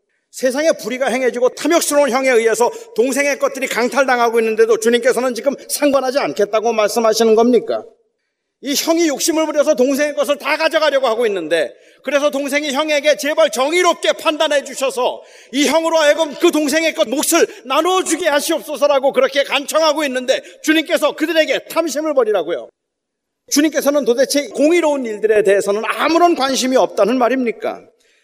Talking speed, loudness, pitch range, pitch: 395 characters per minute, -15 LUFS, 260-320 Hz, 290 Hz